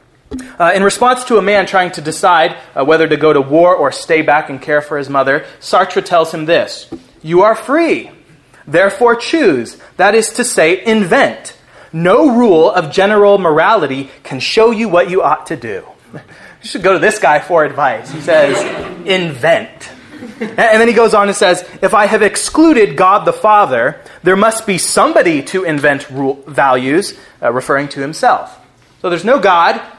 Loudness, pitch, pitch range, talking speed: -11 LUFS, 190 Hz, 155-225 Hz, 180 wpm